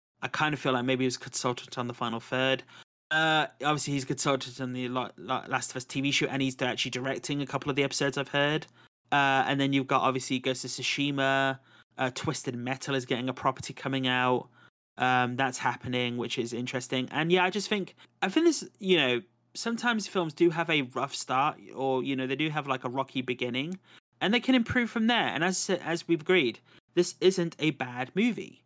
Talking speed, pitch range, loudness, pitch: 215 wpm, 130-160 Hz, -28 LUFS, 135 Hz